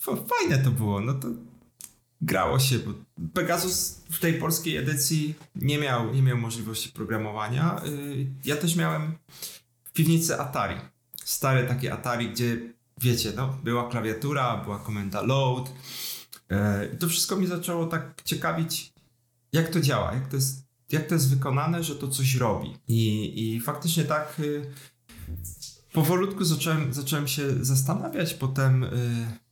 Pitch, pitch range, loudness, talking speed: 135 Hz, 120-155 Hz, -27 LUFS, 135 wpm